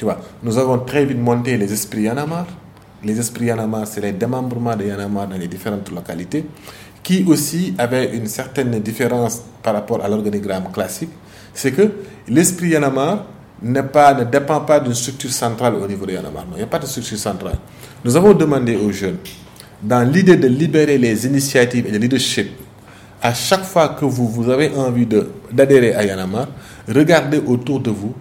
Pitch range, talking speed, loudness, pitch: 105-140 Hz, 185 wpm, -17 LUFS, 120 Hz